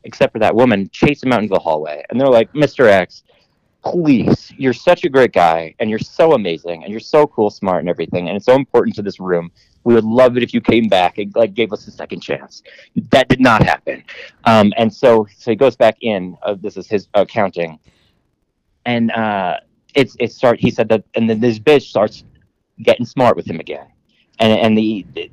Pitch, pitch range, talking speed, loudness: 110 Hz, 95-120 Hz, 220 wpm, -15 LUFS